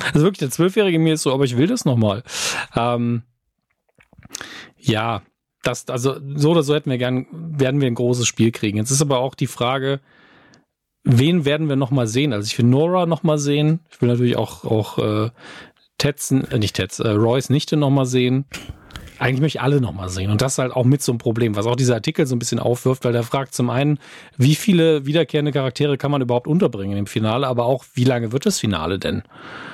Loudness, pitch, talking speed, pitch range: -19 LUFS, 130 Hz, 215 wpm, 120-150 Hz